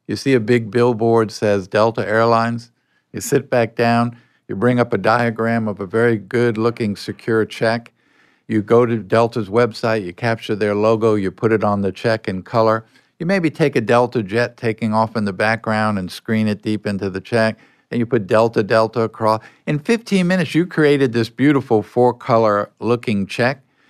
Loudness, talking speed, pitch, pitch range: -18 LUFS, 185 wpm, 115 Hz, 110-120 Hz